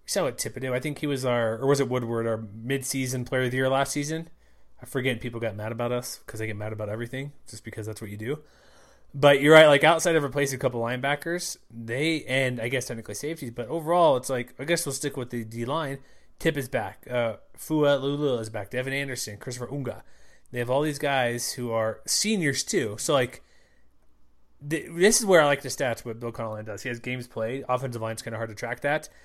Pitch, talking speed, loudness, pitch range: 130 Hz, 235 wpm, -26 LUFS, 115-145 Hz